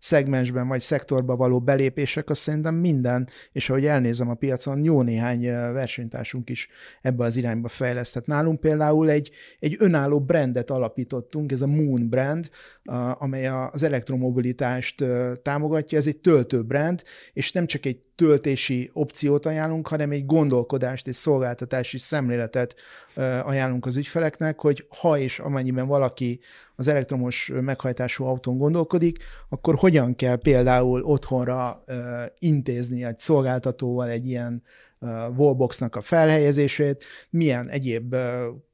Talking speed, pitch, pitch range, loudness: 125 wpm, 130 Hz, 125-150 Hz, -23 LUFS